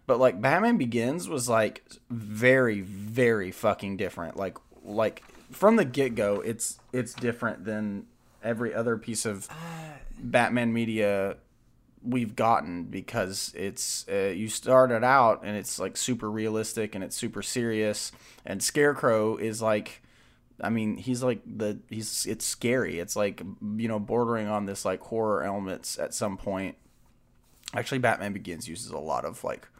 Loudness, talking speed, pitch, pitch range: -28 LUFS, 155 wpm, 110 Hz, 105-125 Hz